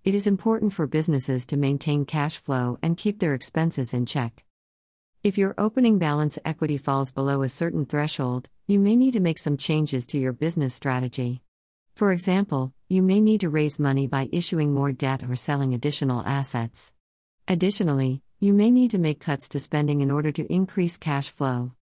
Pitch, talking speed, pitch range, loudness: 145 Hz, 185 wpm, 135-180 Hz, -24 LUFS